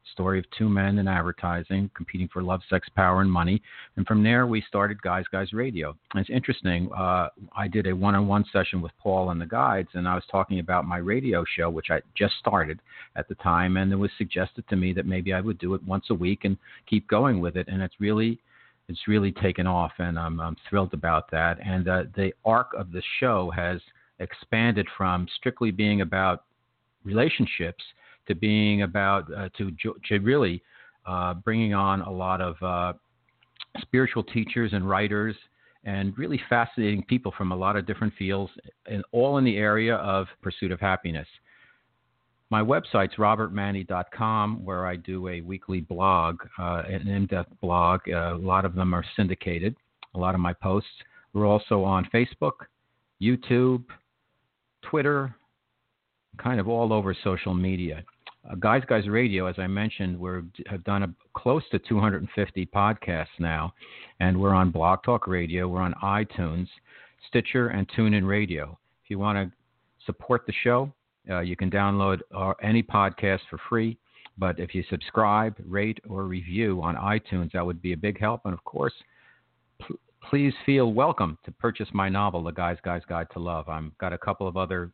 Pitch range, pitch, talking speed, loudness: 90-110 Hz, 95 Hz, 180 wpm, -26 LUFS